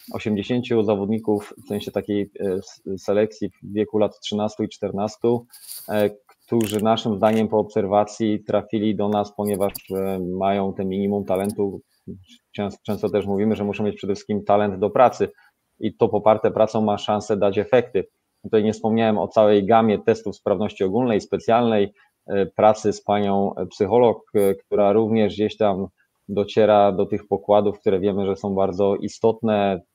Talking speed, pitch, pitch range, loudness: 145 wpm, 105 Hz, 100-110 Hz, -21 LUFS